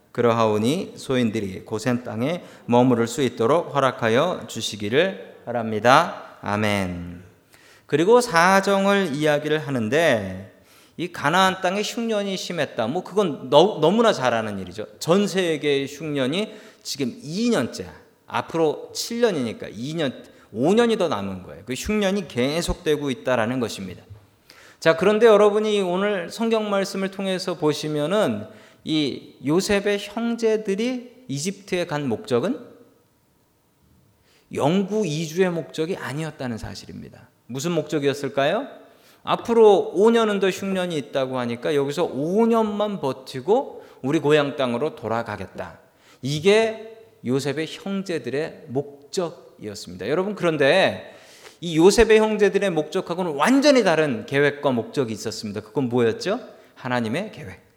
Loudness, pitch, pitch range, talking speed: -22 LUFS, 155 Hz, 125-200 Hz, 290 characters per minute